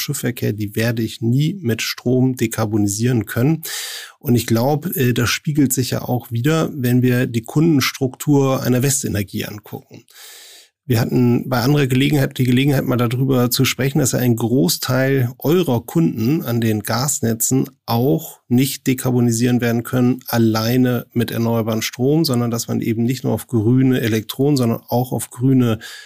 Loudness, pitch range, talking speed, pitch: -18 LUFS, 115-135 Hz, 155 wpm, 125 Hz